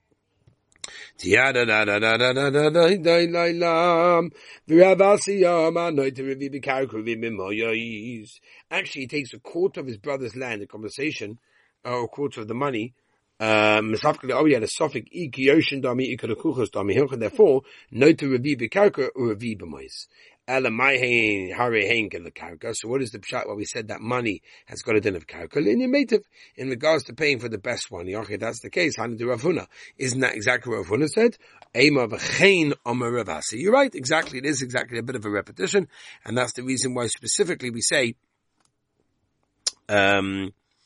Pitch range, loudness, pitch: 115-165 Hz, -22 LUFS, 130 Hz